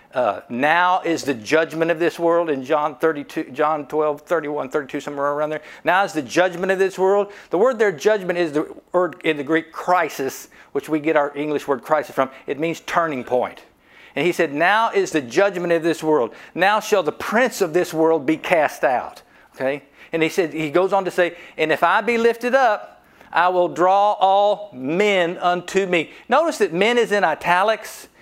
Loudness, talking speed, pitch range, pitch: -20 LUFS, 205 wpm, 155-195 Hz, 170 Hz